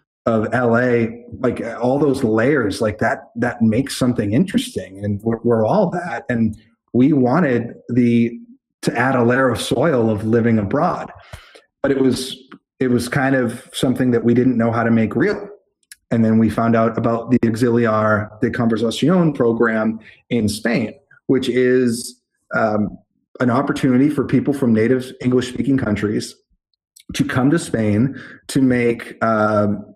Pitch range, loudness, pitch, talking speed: 115-130 Hz, -18 LUFS, 120 Hz, 155 wpm